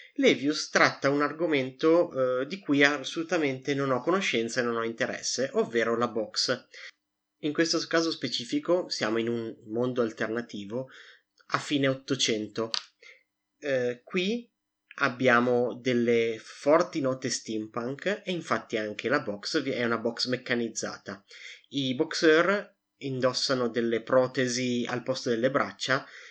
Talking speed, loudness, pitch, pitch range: 125 wpm, -28 LUFS, 130 Hz, 120-150 Hz